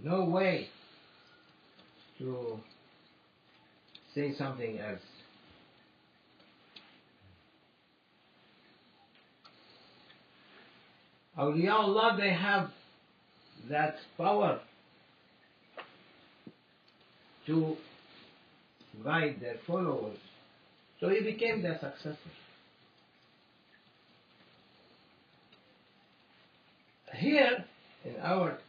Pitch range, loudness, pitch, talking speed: 140-200 Hz, -32 LUFS, 160 Hz, 50 wpm